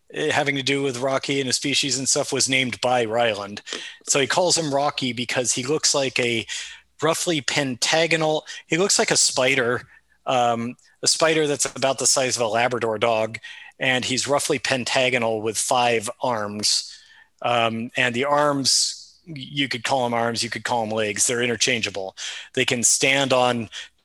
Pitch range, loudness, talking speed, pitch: 120-140 Hz, -21 LUFS, 170 wpm, 130 Hz